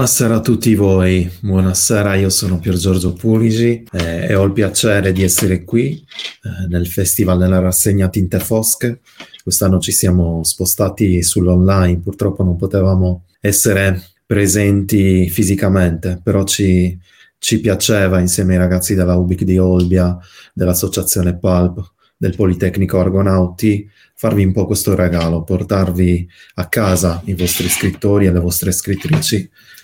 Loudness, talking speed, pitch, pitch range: -14 LUFS, 135 wpm, 95 Hz, 90-100 Hz